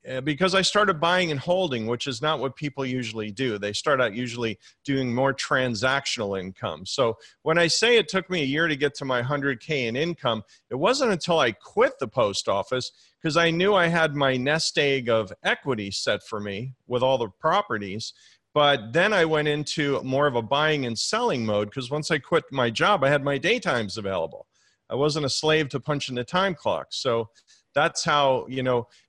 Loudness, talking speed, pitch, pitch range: -24 LUFS, 205 wpm, 135 Hz, 120-155 Hz